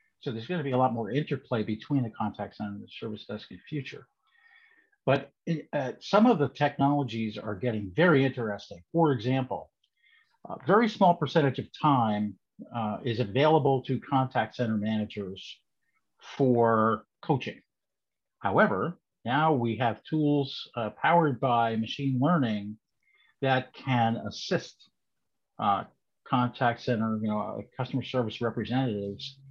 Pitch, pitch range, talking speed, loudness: 130 Hz, 110-145 Hz, 140 wpm, -28 LUFS